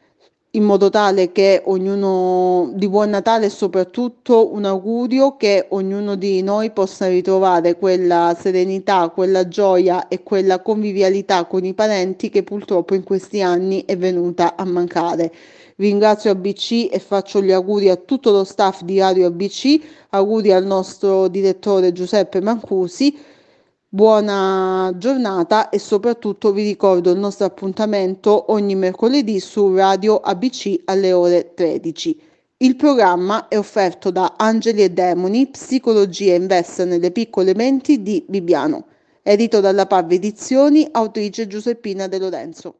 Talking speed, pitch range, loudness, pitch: 135 wpm, 185-215 Hz, -16 LUFS, 195 Hz